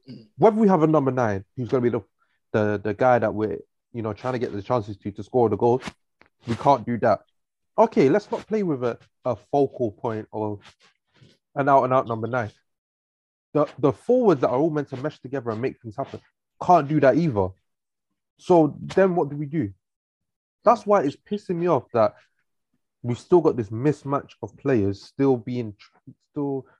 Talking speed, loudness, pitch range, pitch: 200 wpm, -23 LUFS, 110-150 Hz, 125 Hz